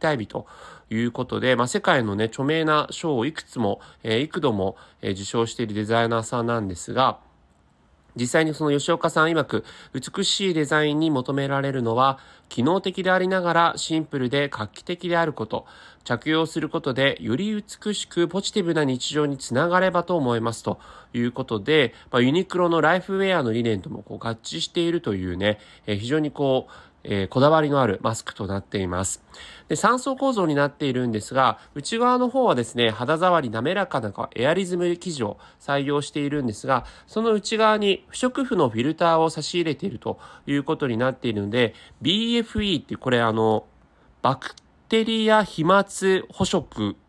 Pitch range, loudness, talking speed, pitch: 115-175 Hz, -23 LUFS, 365 characters per minute, 145 Hz